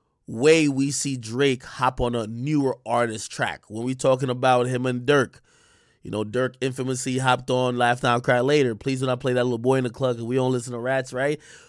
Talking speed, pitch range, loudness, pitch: 220 wpm, 120-135 Hz, -23 LUFS, 130 Hz